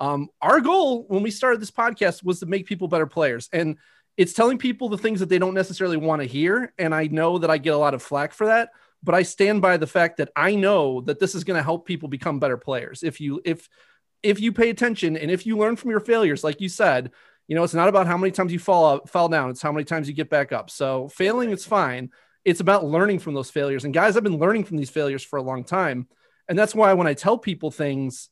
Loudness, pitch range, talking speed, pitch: -22 LUFS, 155-205 Hz, 265 wpm, 180 Hz